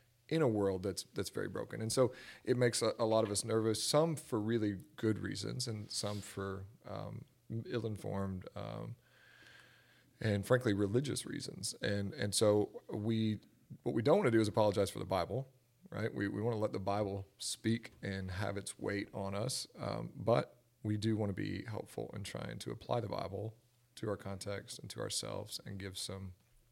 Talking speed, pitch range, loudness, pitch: 195 wpm, 100-120 Hz, -37 LUFS, 105 Hz